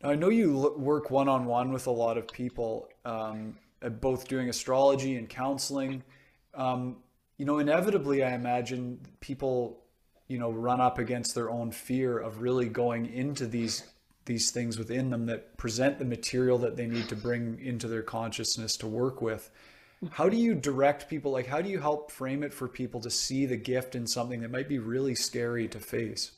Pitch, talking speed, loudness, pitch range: 125 Hz, 190 wpm, -31 LUFS, 115-135 Hz